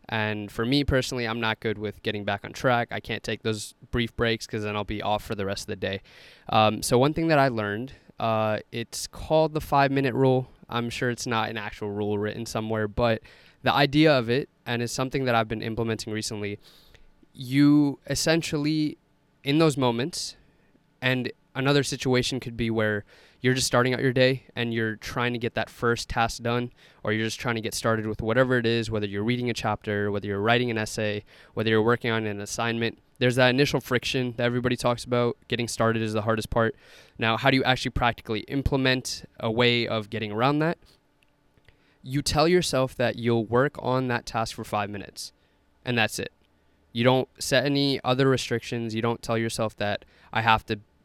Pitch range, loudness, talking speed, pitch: 110-130 Hz, -26 LUFS, 205 wpm, 120 Hz